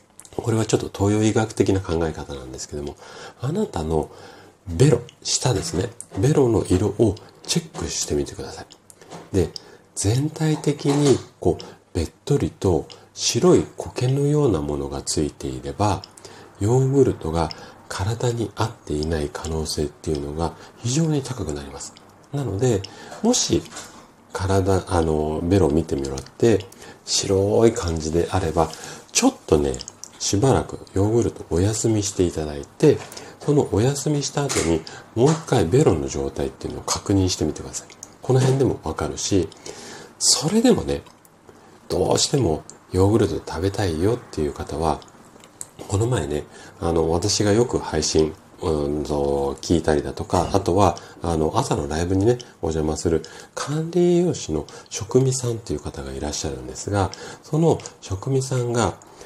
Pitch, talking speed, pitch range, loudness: 95 Hz, 305 characters per minute, 80-120 Hz, -22 LUFS